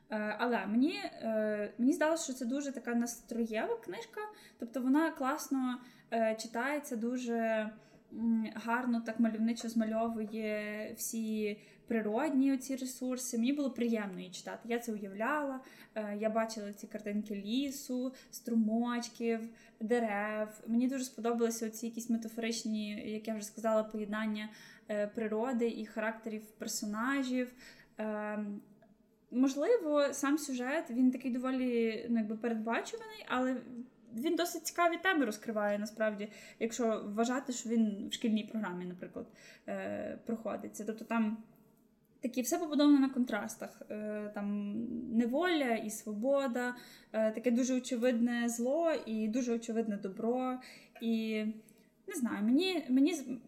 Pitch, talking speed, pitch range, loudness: 230 Hz, 115 wpm, 220-255 Hz, -35 LUFS